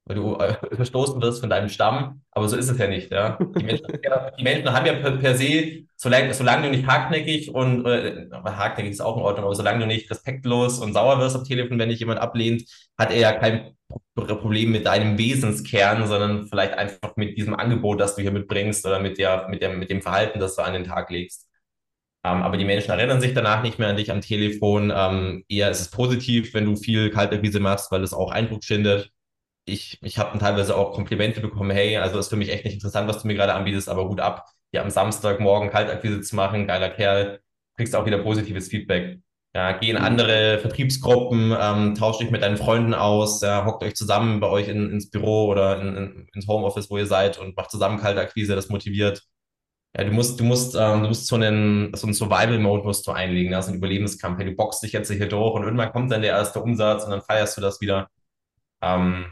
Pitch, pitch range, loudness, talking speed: 105 Hz, 100-115 Hz, -22 LUFS, 230 wpm